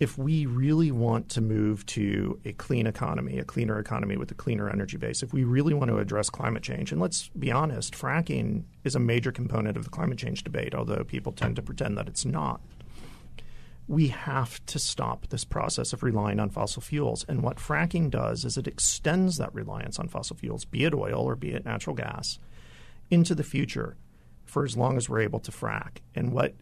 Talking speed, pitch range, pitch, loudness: 205 wpm, 105-145 Hz, 120 Hz, -29 LUFS